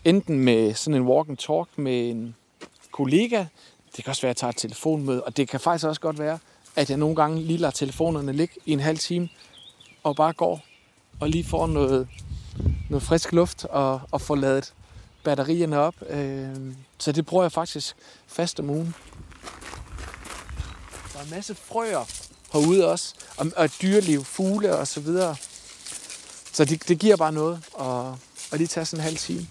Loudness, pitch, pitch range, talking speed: -25 LUFS, 150 Hz, 130-165 Hz, 185 wpm